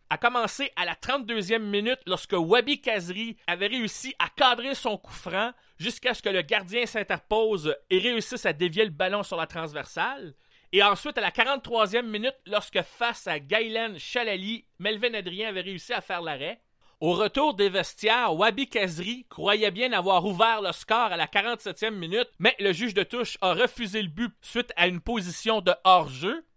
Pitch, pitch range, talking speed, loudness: 220 Hz, 195-240 Hz, 180 wpm, -26 LUFS